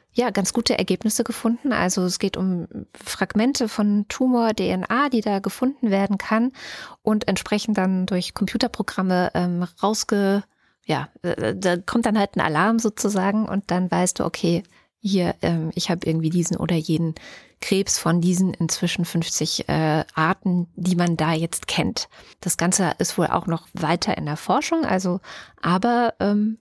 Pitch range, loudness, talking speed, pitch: 175-220 Hz, -22 LUFS, 160 wpm, 190 Hz